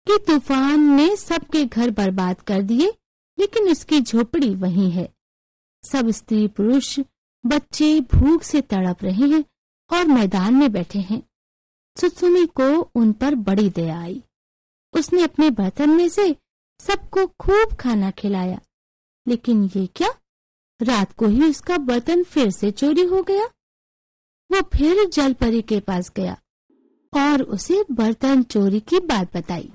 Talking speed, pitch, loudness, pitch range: 140 wpm, 270 Hz, -19 LUFS, 210-330 Hz